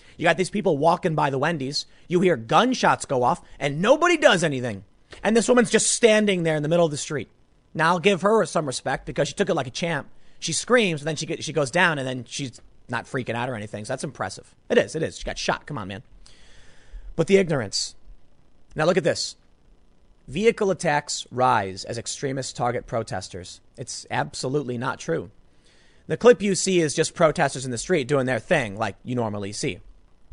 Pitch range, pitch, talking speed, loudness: 120-180 Hz, 150 Hz, 210 wpm, -23 LUFS